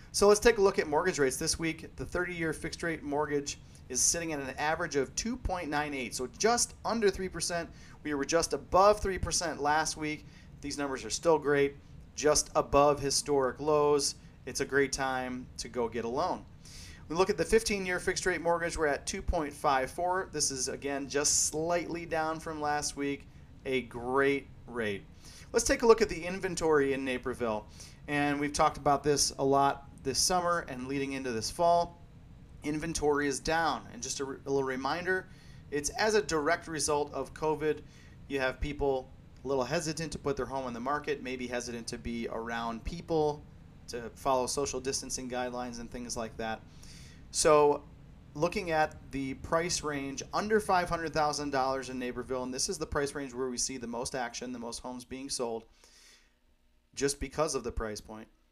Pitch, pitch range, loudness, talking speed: 145 Hz, 130-165 Hz, -31 LUFS, 180 wpm